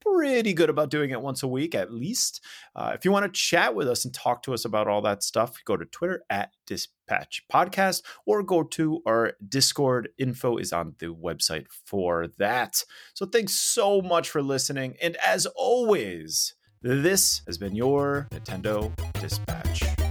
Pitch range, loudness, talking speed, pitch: 100-165 Hz, -26 LUFS, 175 wpm, 130 Hz